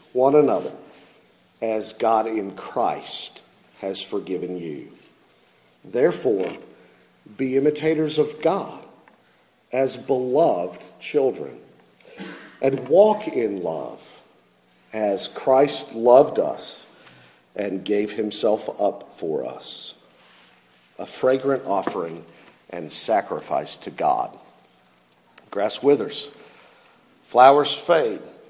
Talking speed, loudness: 90 wpm, -22 LUFS